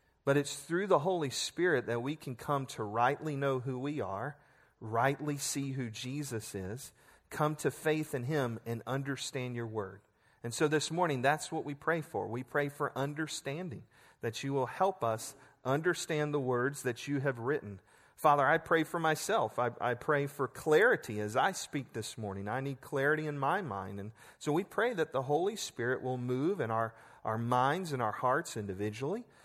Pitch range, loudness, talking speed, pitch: 115-150 Hz, -34 LUFS, 190 wpm, 135 Hz